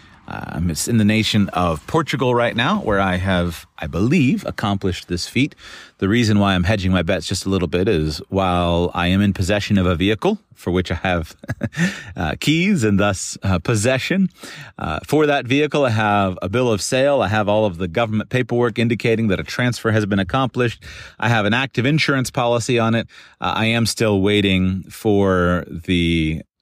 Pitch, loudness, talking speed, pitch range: 105 Hz, -19 LUFS, 195 wpm, 95-120 Hz